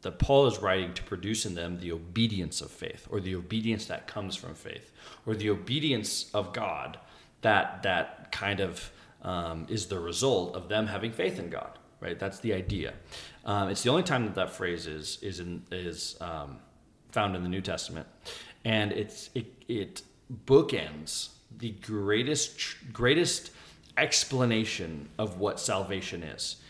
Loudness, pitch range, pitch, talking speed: -31 LUFS, 90-110 Hz, 100 Hz, 165 wpm